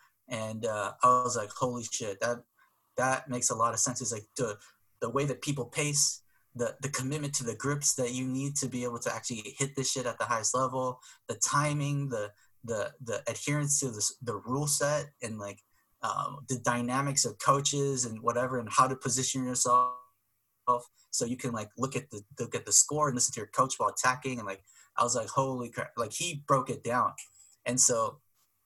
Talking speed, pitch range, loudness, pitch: 210 wpm, 120-135 Hz, -30 LUFS, 125 Hz